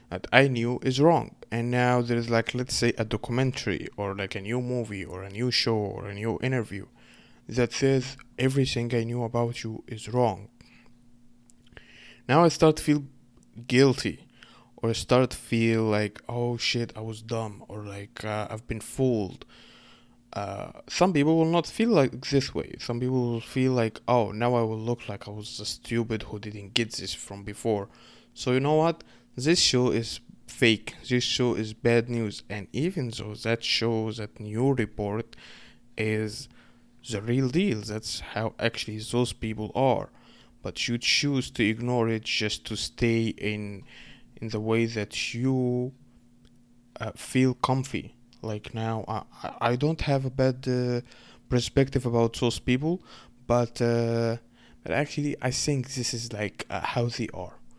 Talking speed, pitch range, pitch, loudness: 170 wpm, 110-125 Hz, 120 Hz, -27 LUFS